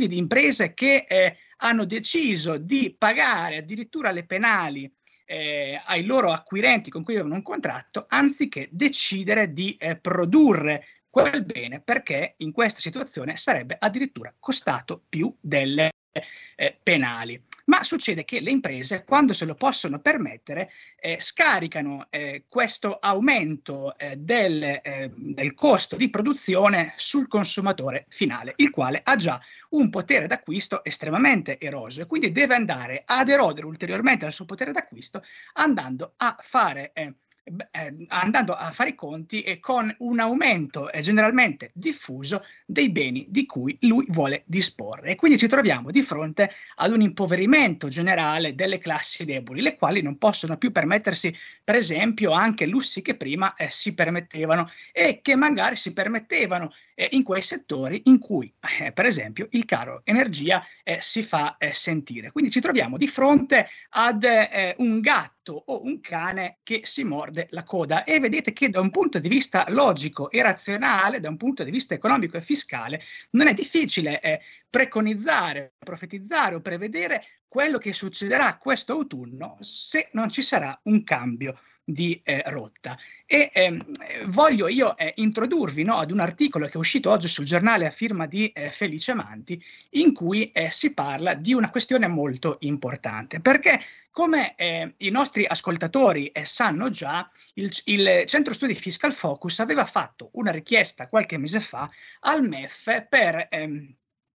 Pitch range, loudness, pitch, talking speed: 160-255 Hz, -23 LUFS, 200 Hz, 155 wpm